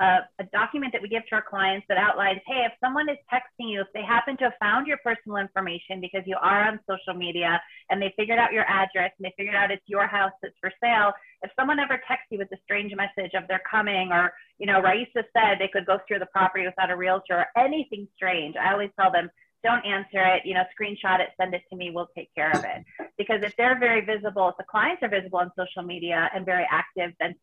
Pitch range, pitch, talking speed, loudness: 185-215 Hz, 195 Hz, 250 wpm, -25 LUFS